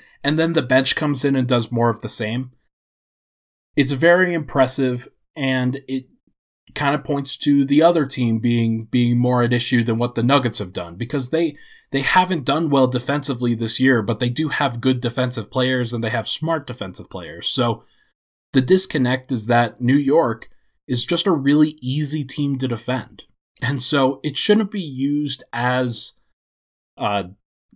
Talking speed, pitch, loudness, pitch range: 175 wpm, 130 Hz, -19 LUFS, 120-145 Hz